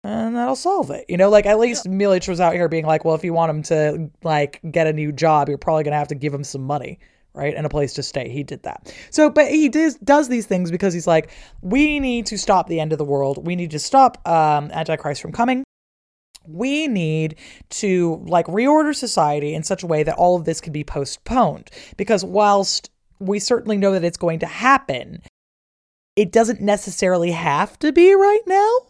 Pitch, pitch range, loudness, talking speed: 175 Hz, 155-230 Hz, -19 LUFS, 220 wpm